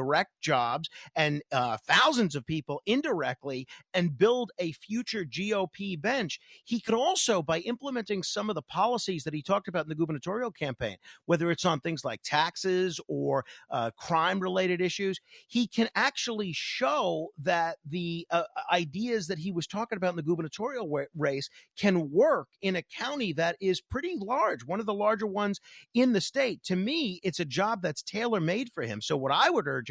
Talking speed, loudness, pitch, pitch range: 185 wpm, -29 LUFS, 185 Hz, 165-220 Hz